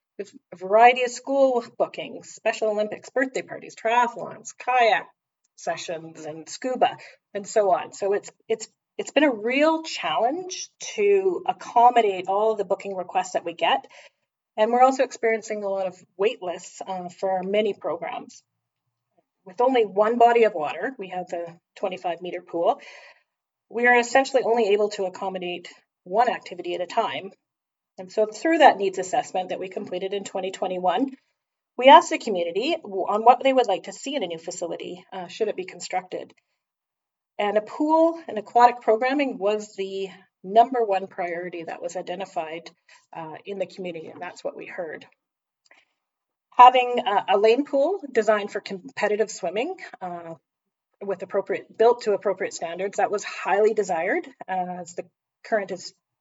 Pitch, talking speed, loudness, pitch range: 210 Hz, 160 wpm, -23 LUFS, 185-245 Hz